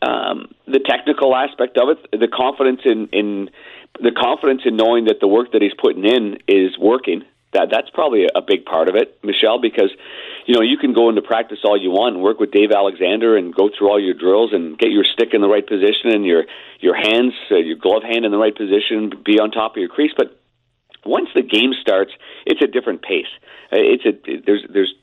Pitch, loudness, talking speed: 130 Hz, -16 LUFS, 225 wpm